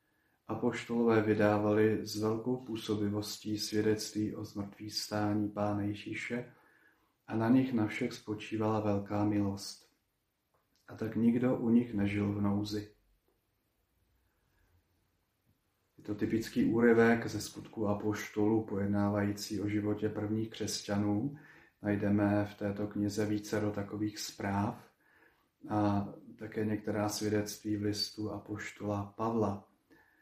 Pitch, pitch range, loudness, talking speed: 105 Hz, 105-110 Hz, -34 LUFS, 110 wpm